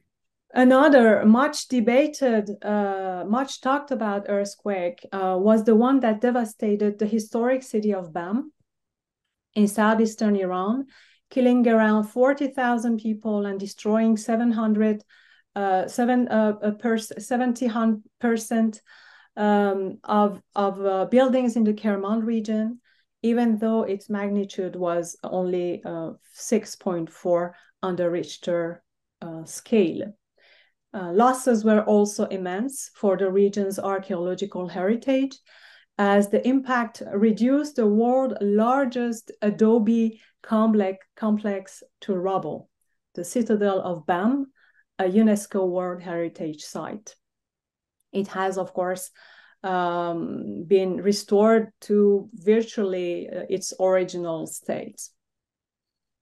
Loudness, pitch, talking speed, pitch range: -23 LUFS, 210 Hz, 105 wpm, 190-230 Hz